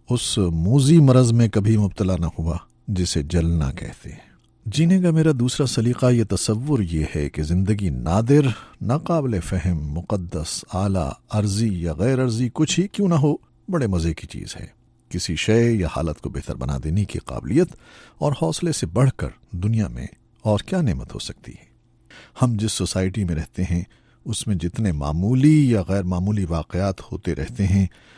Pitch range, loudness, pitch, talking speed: 85-125 Hz, -21 LUFS, 105 Hz, 175 wpm